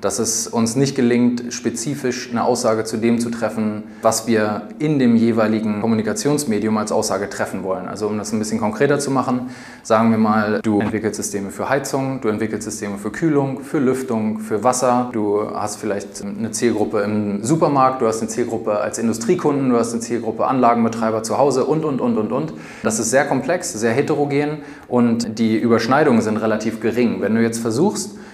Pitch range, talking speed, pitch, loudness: 110-125 Hz, 185 wpm, 115 Hz, -19 LUFS